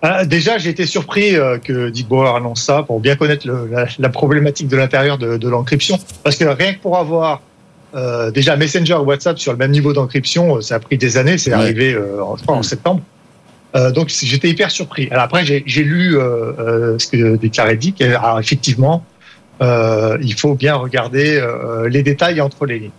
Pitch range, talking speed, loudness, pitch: 120-155 Hz, 200 wpm, -14 LUFS, 140 Hz